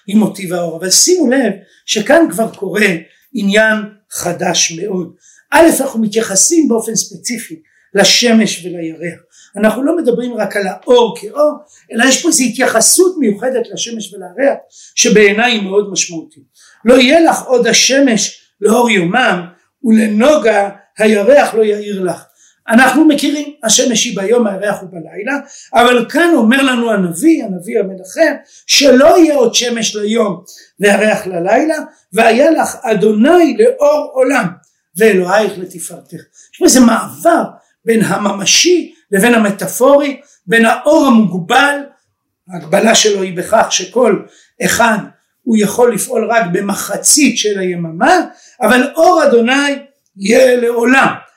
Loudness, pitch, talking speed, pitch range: -11 LUFS, 225 Hz, 125 wpm, 195-270 Hz